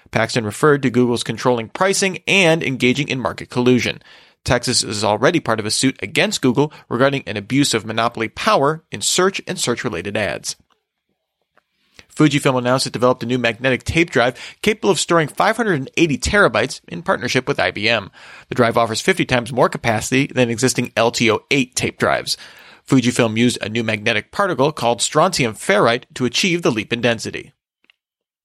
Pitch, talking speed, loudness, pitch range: 125 Hz, 160 wpm, -17 LUFS, 115-145 Hz